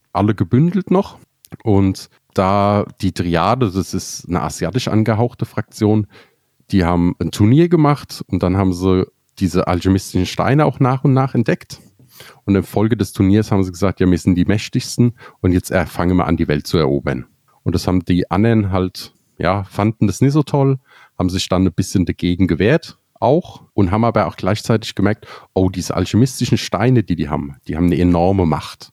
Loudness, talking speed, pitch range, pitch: -17 LUFS, 185 wpm, 90-120 Hz, 100 Hz